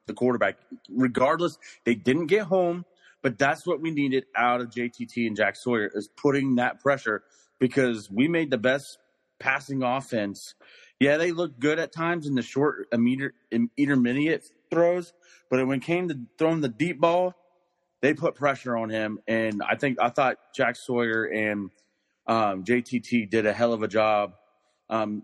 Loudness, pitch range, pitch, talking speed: -26 LUFS, 115-160 Hz, 130 Hz, 170 wpm